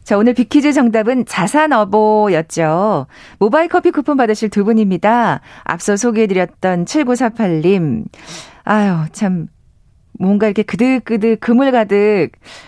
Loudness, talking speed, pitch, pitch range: -14 LUFS, 260 characters per minute, 215 Hz, 200-245 Hz